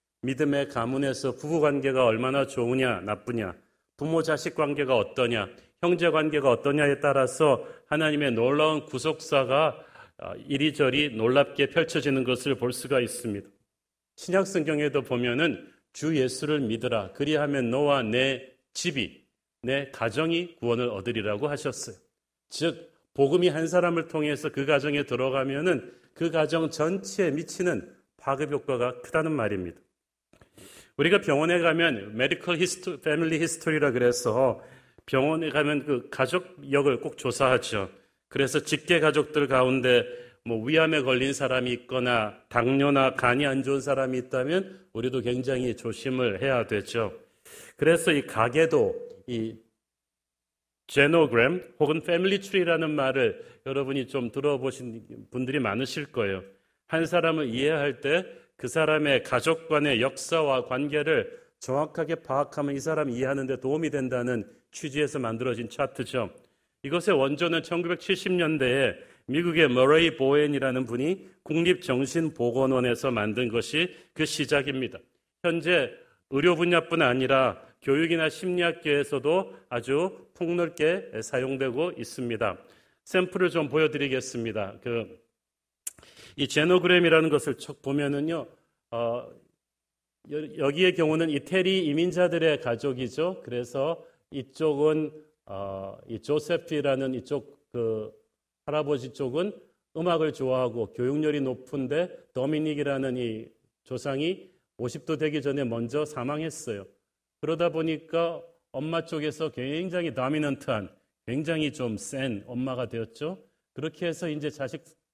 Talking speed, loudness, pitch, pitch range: 290 characters per minute, -26 LUFS, 145 Hz, 125-160 Hz